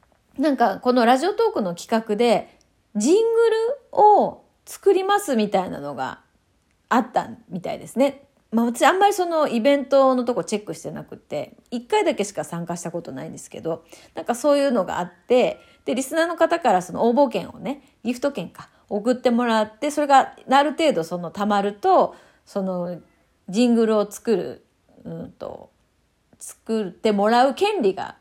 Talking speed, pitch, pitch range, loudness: 340 characters per minute, 245 Hz, 205-295 Hz, -21 LUFS